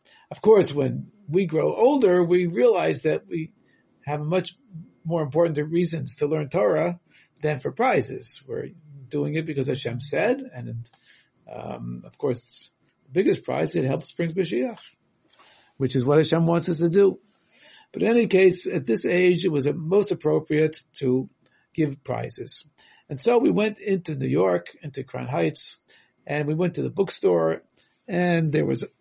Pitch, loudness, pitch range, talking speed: 160 Hz, -23 LUFS, 145-180 Hz, 165 wpm